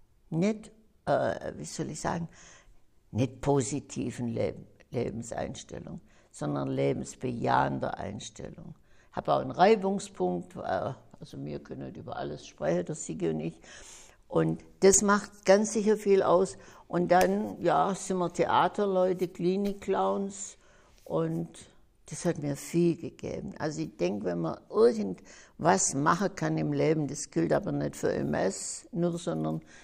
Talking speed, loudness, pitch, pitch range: 135 wpm, -29 LUFS, 170 Hz, 120-190 Hz